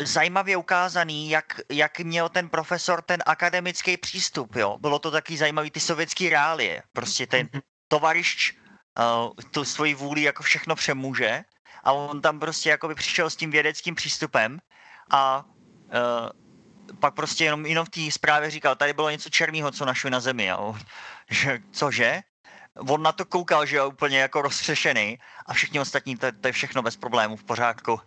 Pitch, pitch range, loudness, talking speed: 150 Hz, 135-165 Hz, -24 LUFS, 170 wpm